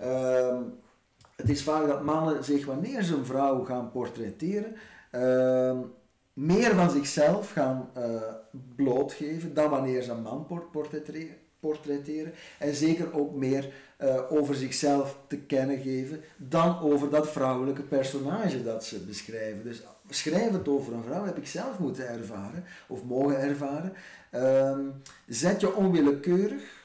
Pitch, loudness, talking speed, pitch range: 140 Hz, -29 LUFS, 135 wpm, 130-155 Hz